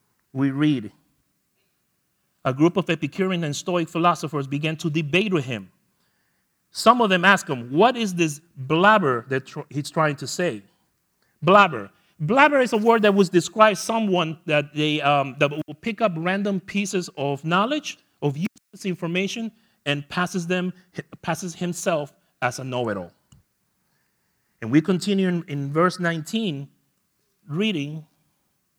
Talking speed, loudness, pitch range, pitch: 140 wpm, -22 LUFS, 145-195 Hz, 170 Hz